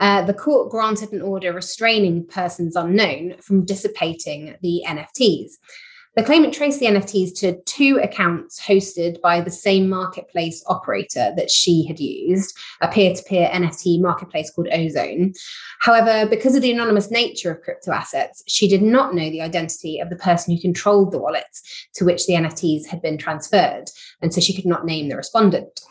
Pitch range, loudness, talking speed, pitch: 170-210 Hz, -19 LUFS, 175 wpm, 185 Hz